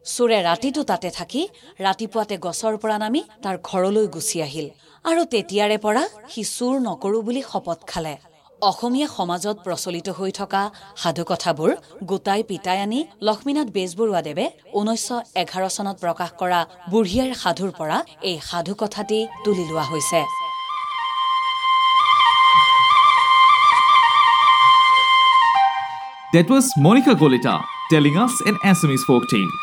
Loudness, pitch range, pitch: -18 LUFS, 165-225 Hz, 195 Hz